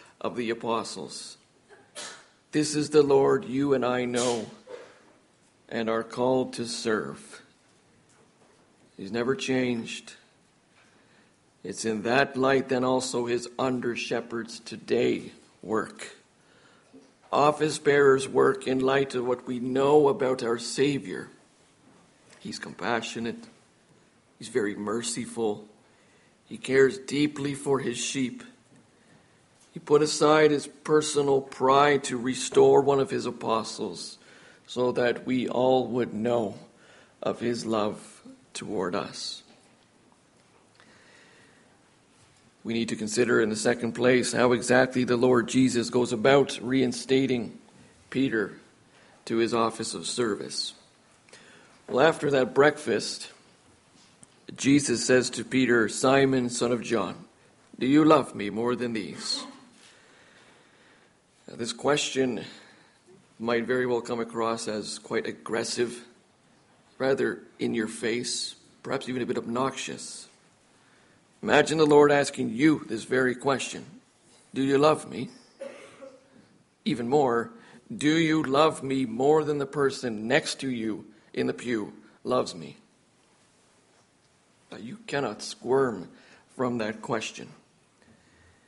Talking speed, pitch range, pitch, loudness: 120 wpm, 120-140 Hz, 125 Hz, -26 LUFS